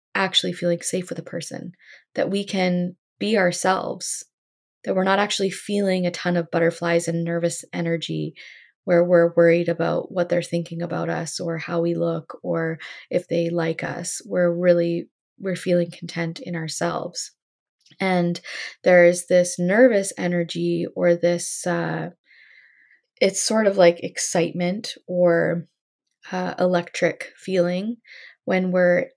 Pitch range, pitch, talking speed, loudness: 170-185 Hz, 175 Hz, 140 wpm, -22 LUFS